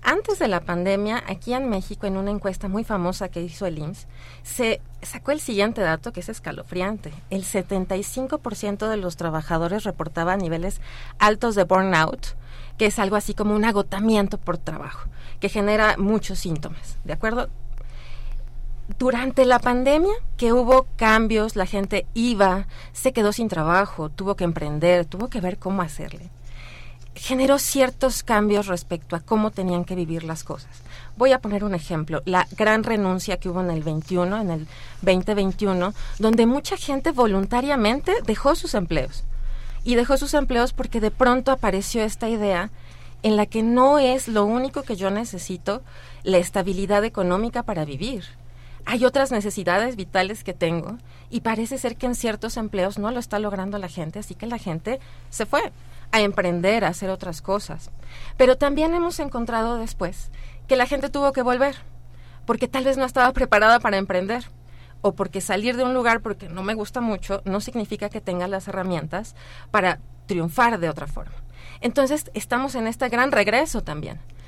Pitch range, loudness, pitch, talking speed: 175-235 Hz, -23 LUFS, 200 Hz, 170 wpm